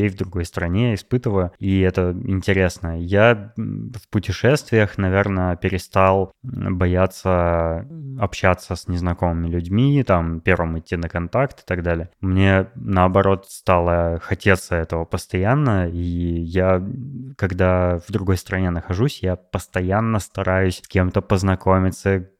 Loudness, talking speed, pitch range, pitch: -20 LUFS, 120 wpm, 90-100 Hz, 95 Hz